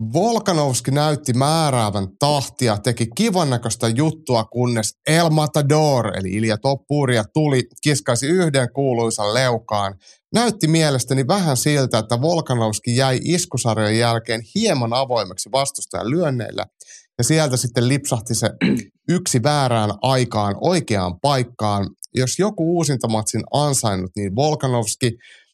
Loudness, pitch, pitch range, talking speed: -19 LUFS, 130 Hz, 115-150 Hz, 115 wpm